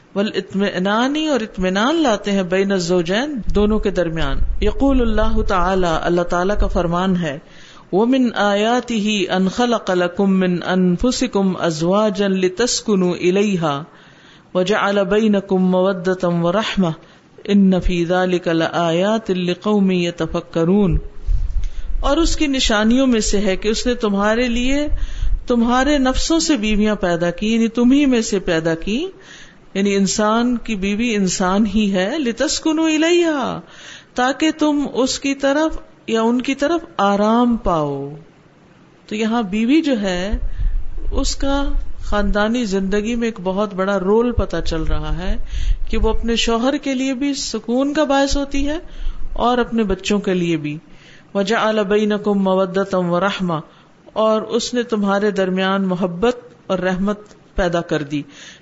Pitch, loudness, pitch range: 205 Hz, -18 LUFS, 185-240 Hz